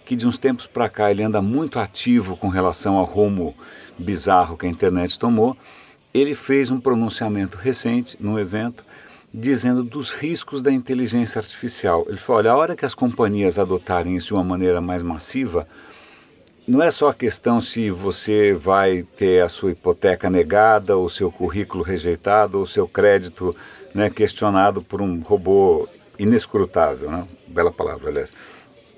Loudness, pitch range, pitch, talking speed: -20 LUFS, 95-125 Hz, 105 Hz, 160 wpm